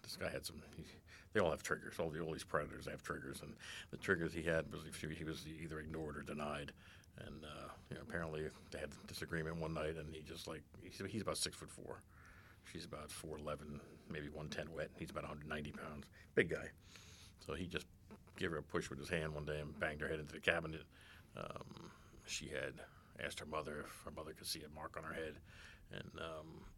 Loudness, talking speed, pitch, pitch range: -45 LUFS, 220 wpm, 80 Hz, 75-90 Hz